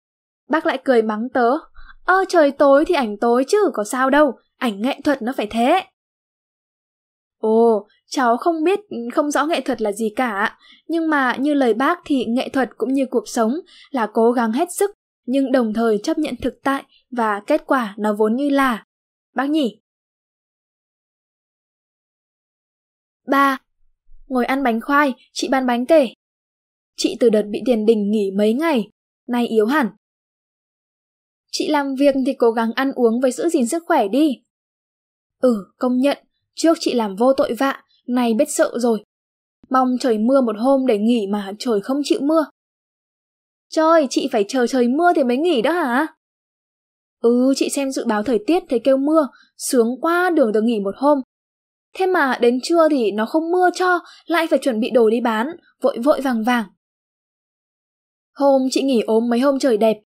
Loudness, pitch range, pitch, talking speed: -18 LUFS, 235-300 Hz, 265 Hz, 180 wpm